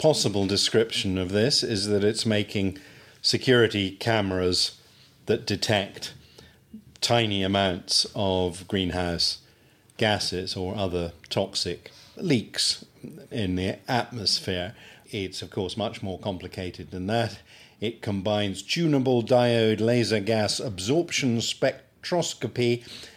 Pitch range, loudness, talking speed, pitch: 95-120 Hz, -25 LUFS, 105 wpm, 105 Hz